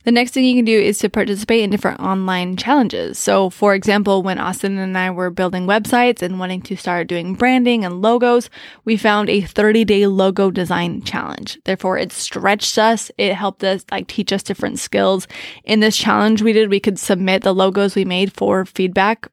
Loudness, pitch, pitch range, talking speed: -16 LUFS, 200 Hz, 190-220 Hz, 200 wpm